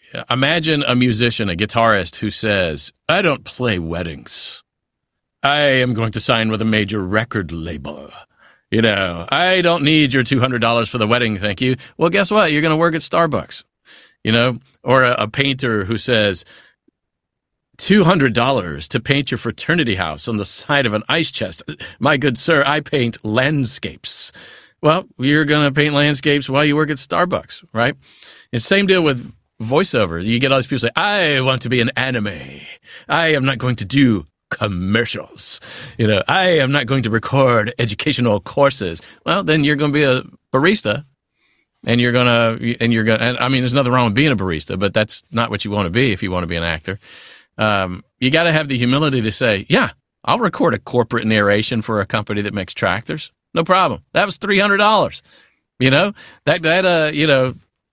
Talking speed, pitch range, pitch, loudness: 200 wpm, 110-145 Hz, 125 Hz, -16 LUFS